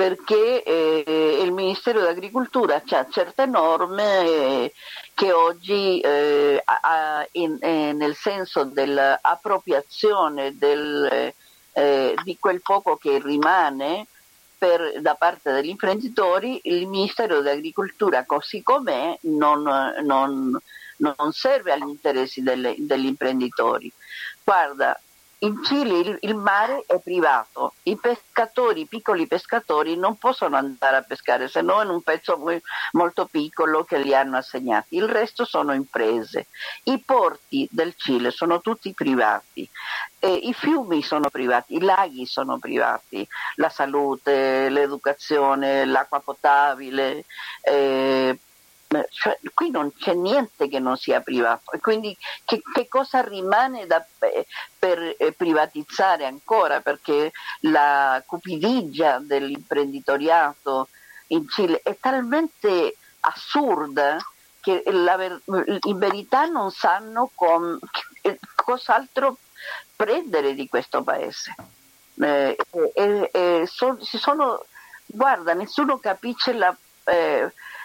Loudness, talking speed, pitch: -22 LUFS, 115 wpm, 180 Hz